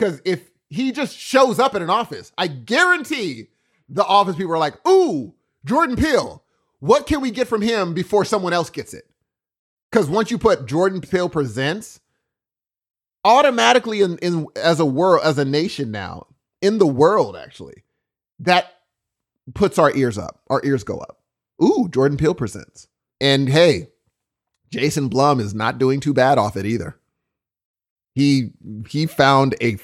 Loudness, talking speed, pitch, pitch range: -18 LUFS, 160 wpm, 160 Hz, 135-205 Hz